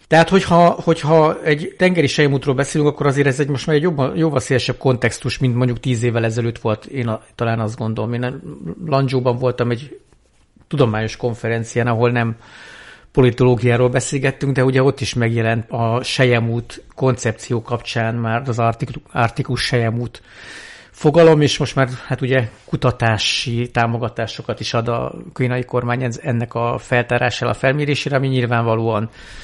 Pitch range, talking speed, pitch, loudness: 115-140 Hz, 145 wpm, 125 Hz, -18 LUFS